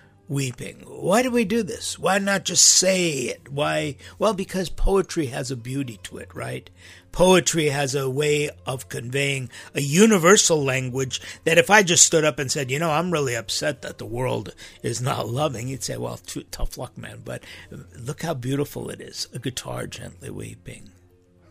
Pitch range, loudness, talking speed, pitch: 120-170 Hz, -21 LUFS, 185 wpm, 140 Hz